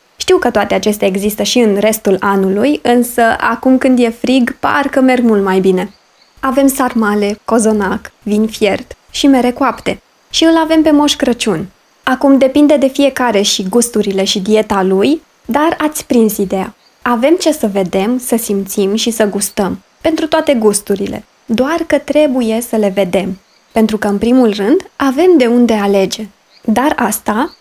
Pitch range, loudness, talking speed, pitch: 205-275 Hz, -12 LUFS, 165 wpm, 230 Hz